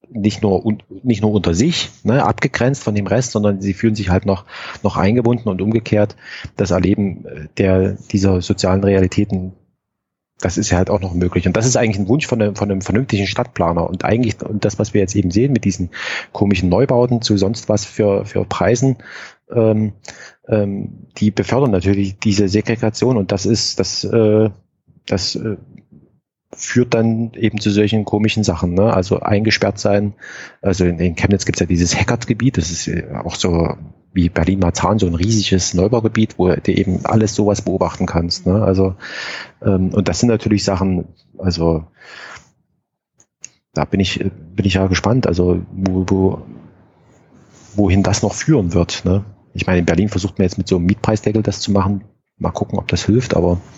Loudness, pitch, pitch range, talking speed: -17 LUFS, 100 Hz, 95-110 Hz, 180 wpm